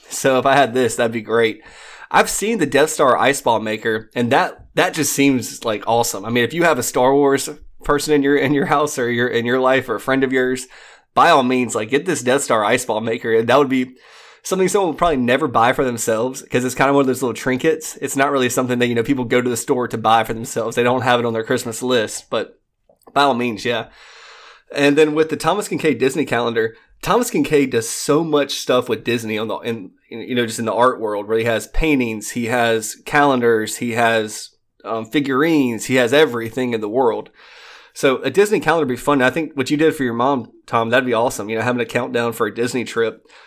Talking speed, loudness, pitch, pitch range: 245 wpm, -18 LUFS, 125 Hz, 115-140 Hz